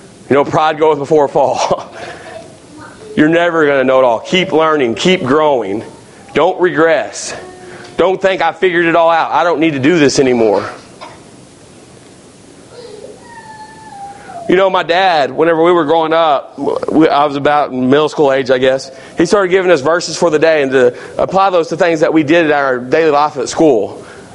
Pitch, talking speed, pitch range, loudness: 165 Hz, 180 wpm, 145-185 Hz, -12 LUFS